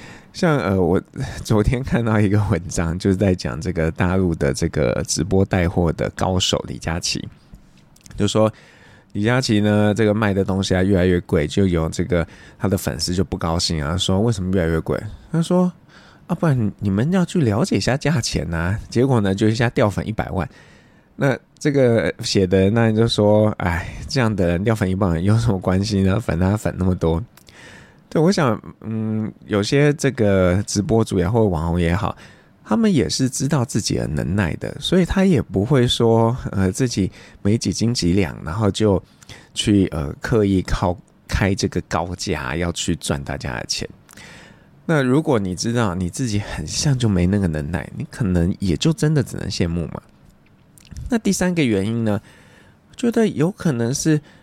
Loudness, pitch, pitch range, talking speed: -20 LUFS, 100 Hz, 90-115 Hz, 260 characters per minute